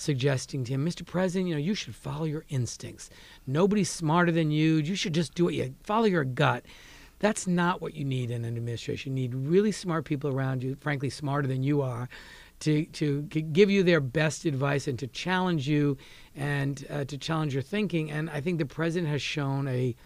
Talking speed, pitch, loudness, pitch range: 210 wpm, 150 Hz, -28 LUFS, 135-170 Hz